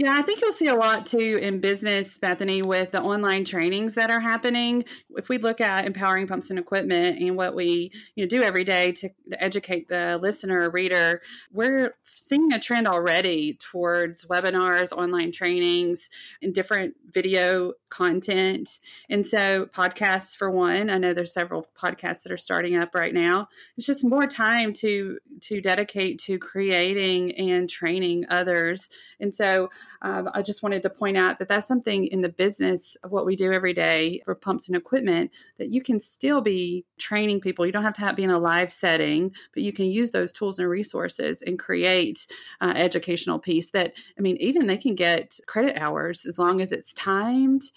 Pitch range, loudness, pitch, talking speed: 180-210 Hz, -24 LUFS, 190 Hz, 185 wpm